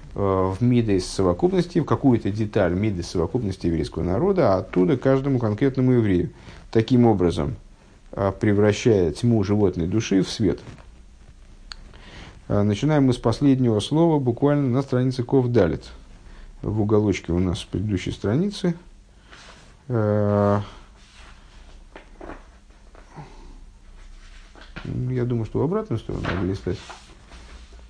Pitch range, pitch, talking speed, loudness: 95-125 Hz, 105 Hz, 100 wpm, -22 LUFS